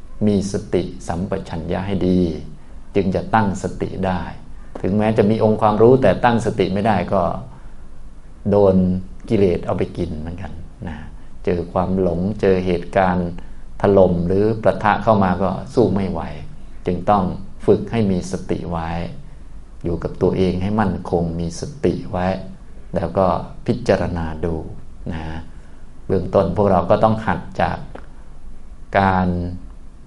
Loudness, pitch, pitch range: -19 LUFS, 90 Hz, 85-100 Hz